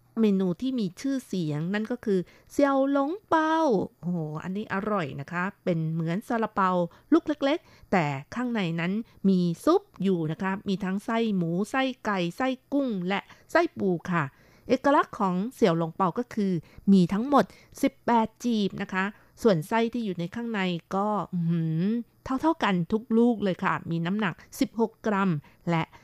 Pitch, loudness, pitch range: 200 Hz, -27 LUFS, 175-235 Hz